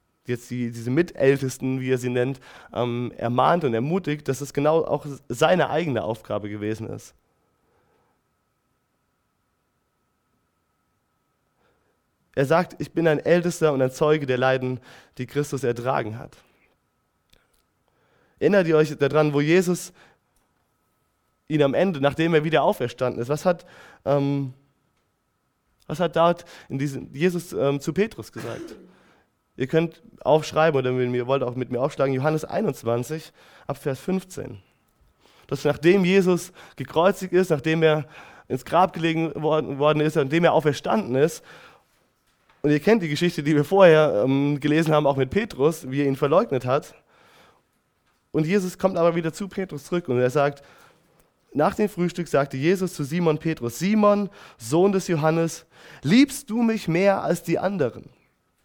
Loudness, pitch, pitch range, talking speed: -23 LUFS, 150 Hz, 135-170 Hz, 145 wpm